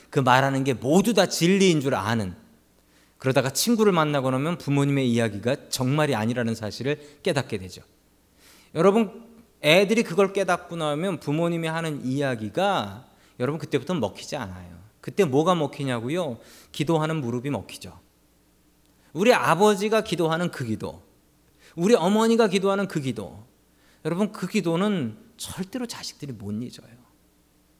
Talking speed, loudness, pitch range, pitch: 320 characters per minute, -24 LUFS, 120-185 Hz, 145 Hz